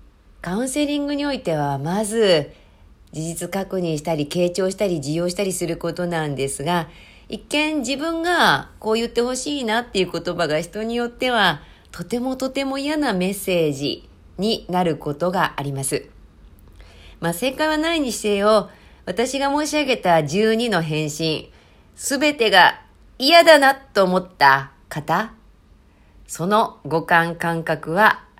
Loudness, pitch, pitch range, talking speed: -20 LUFS, 185 Hz, 165-240 Hz, 275 characters per minute